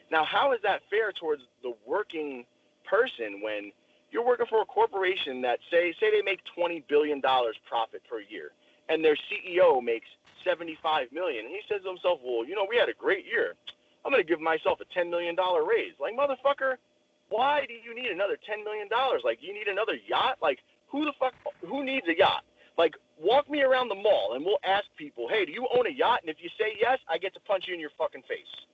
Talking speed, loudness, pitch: 225 wpm, -28 LUFS, 235 Hz